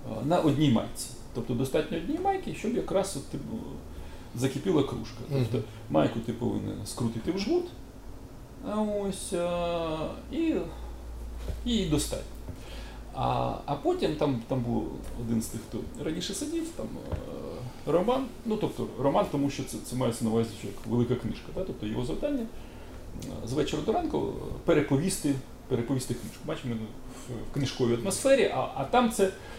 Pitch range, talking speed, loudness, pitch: 115-190 Hz, 145 wpm, -30 LUFS, 125 Hz